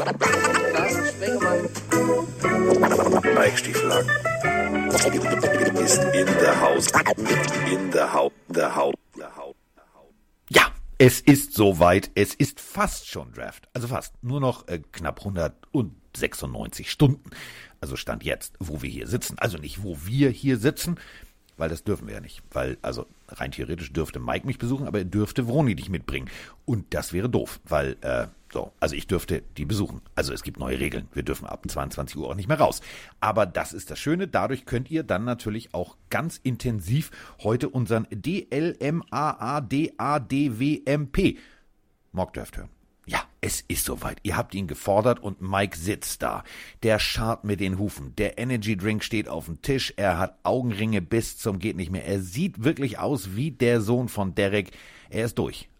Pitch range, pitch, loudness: 95-135 Hz, 115 Hz, -25 LUFS